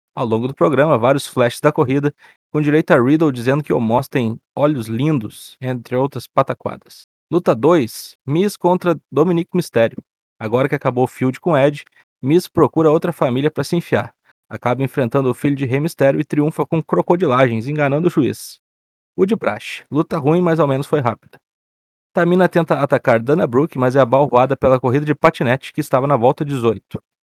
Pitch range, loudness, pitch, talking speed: 125-155 Hz, -17 LUFS, 140 Hz, 180 wpm